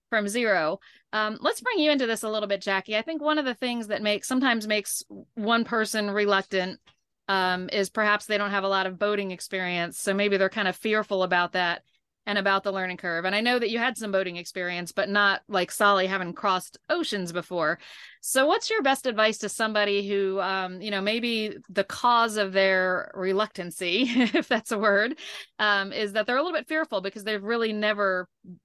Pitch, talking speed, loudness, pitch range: 205 Hz, 205 wpm, -26 LUFS, 190-225 Hz